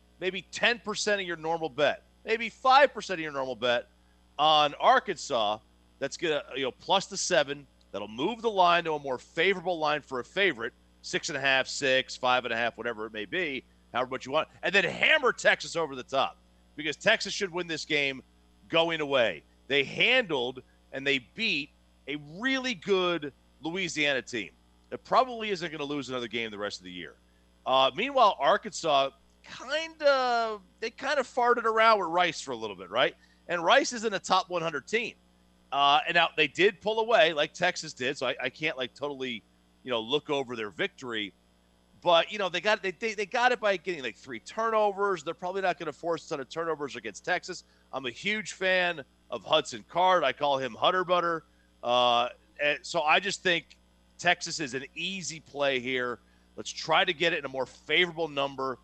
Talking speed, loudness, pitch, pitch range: 200 wpm, -28 LUFS, 150 Hz, 120-185 Hz